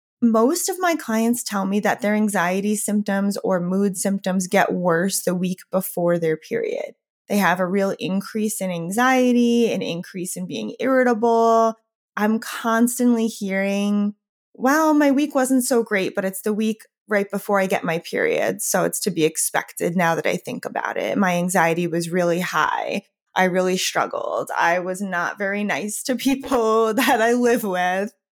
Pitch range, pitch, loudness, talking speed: 185-230 Hz, 205 Hz, -21 LUFS, 170 wpm